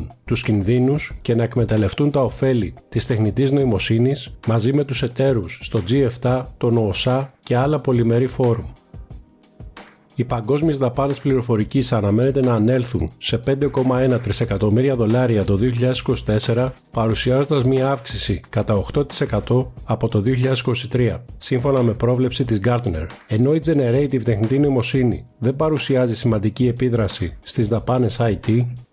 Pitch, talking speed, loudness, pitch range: 125 Hz, 125 wpm, -19 LUFS, 115-130 Hz